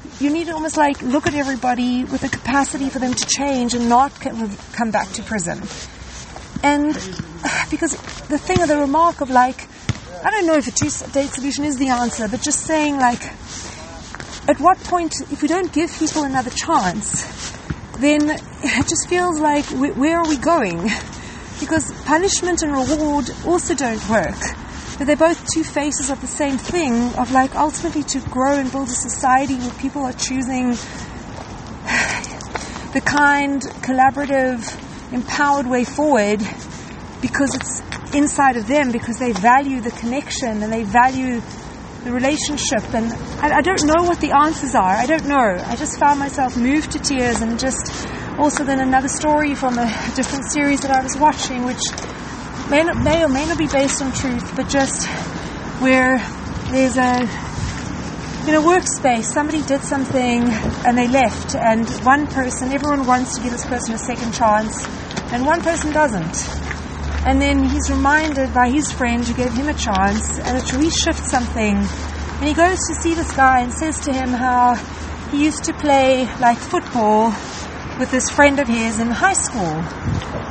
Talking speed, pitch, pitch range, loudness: 170 wpm, 275 Hz, 250-295 Hz, -18 LUFS